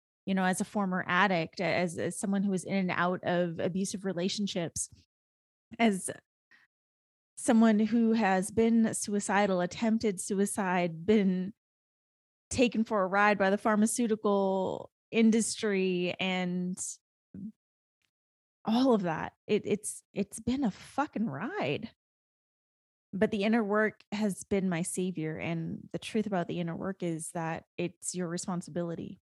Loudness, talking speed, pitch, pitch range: -30 LUFS, 135 wpm, 190 Hz, 175-215 Hz